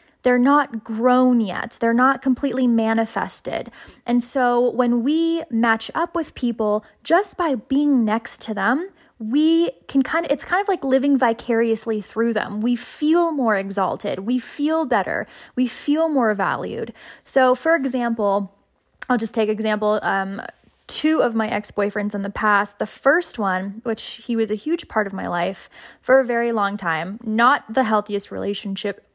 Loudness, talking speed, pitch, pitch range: -20 LUFS, 165 wpm, 240 Hz, 215-275 Hz